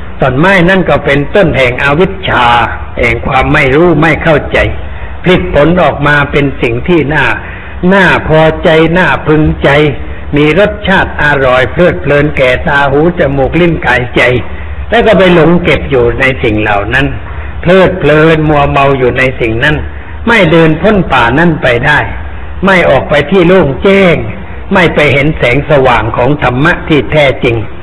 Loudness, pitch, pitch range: -7 LUFS, 145 Hz, 125-170 Hz